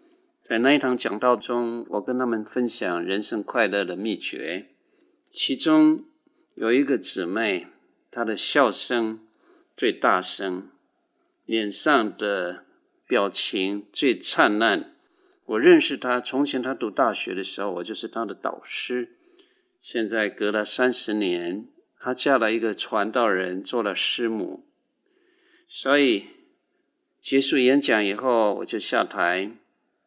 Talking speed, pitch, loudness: 185 characters per minute, 135 Hz, -23 LUFS